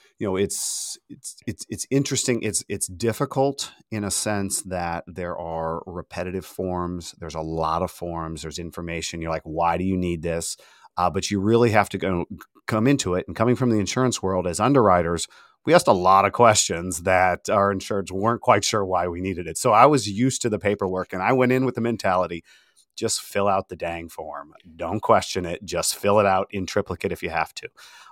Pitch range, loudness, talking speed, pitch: 85-110 Hz, -23 LUFS, 210 wpm, 95 Hz